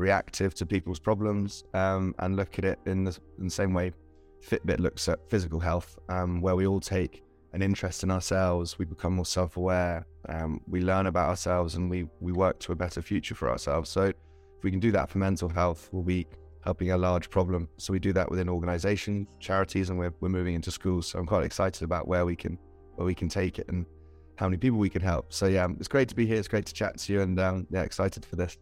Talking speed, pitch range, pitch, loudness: 240 wpm, 85-95 Hz, 90 Hz, -29 LUFS